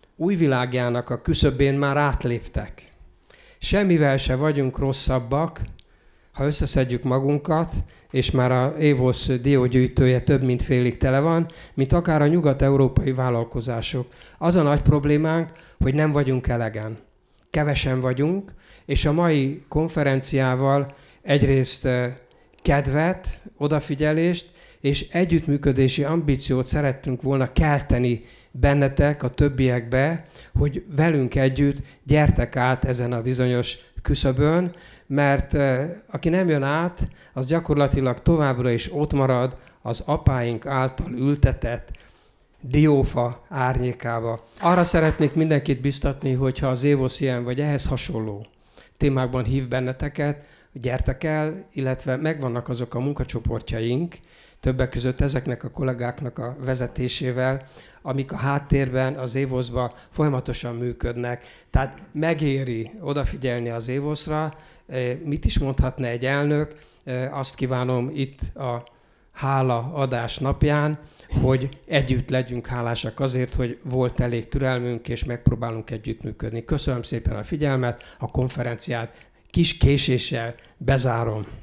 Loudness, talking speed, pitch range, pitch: -23 LUFS, 110 wpm, 125-145 Hz, 135 Hz